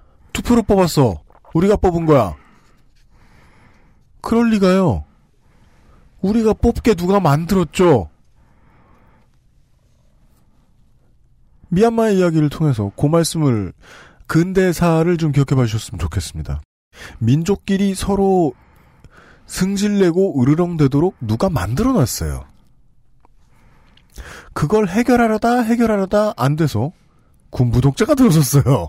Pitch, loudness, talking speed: 160 Hz, -16 LUFS, 230 characters per minute